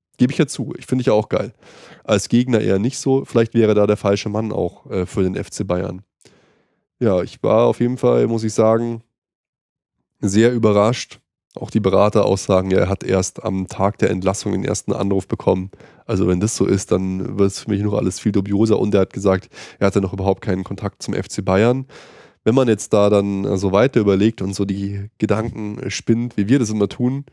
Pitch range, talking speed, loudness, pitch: 95-115 Hz, 210 wpm, -19 LUFS, 105 Hz